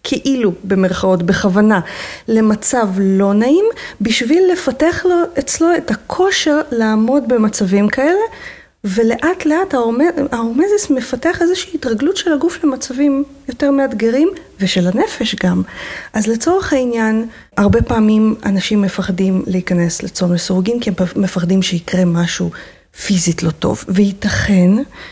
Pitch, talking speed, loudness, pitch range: 225 Hz, 115 wpm, -15 LUFS, 195-295 Hz